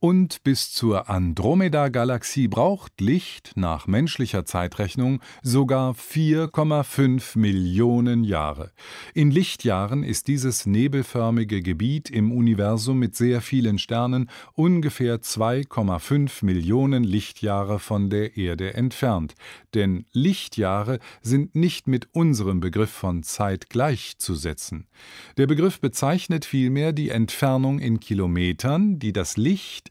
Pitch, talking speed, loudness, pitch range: 120 Hz, 110 wpm, -23 LUFS, 105-140 Hz